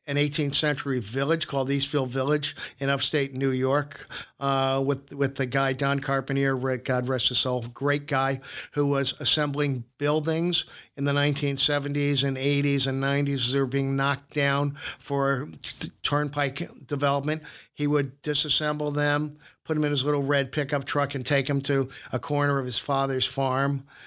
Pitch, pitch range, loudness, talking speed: 140 Hz, 135-145 Hz, -25 LUFS, 160 wpm